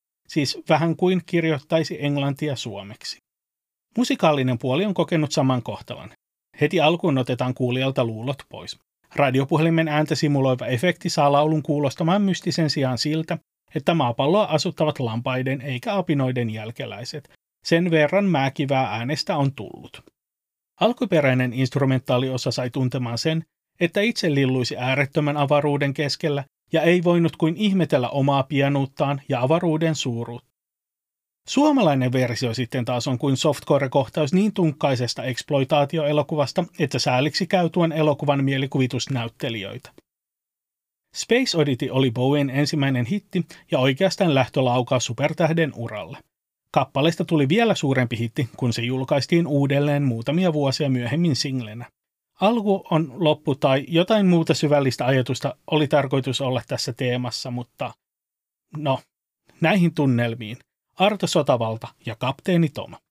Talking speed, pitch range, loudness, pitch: 115 wpm, 130-165 Hz, -22 LUFS, 145 Hz